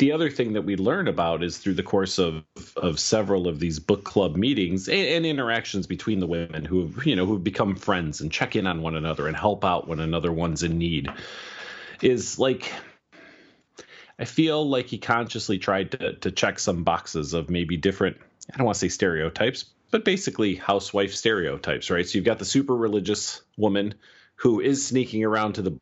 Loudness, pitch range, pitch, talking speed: -25 LUFS, 85-115 Hz, 100 Hz, 200 wpm